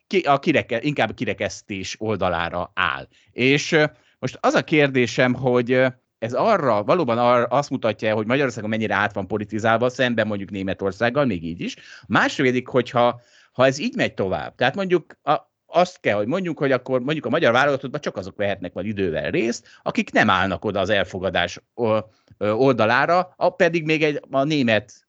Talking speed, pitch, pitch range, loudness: 165 wpm, 125 Hz, 110-140 Hz, -21 LUFS